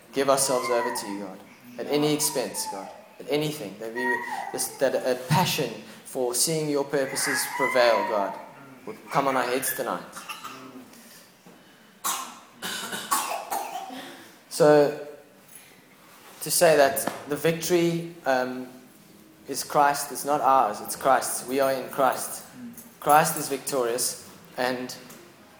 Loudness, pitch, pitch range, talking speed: -25 LUFS, 145 Hz, 130-165 Hz, 120 wpm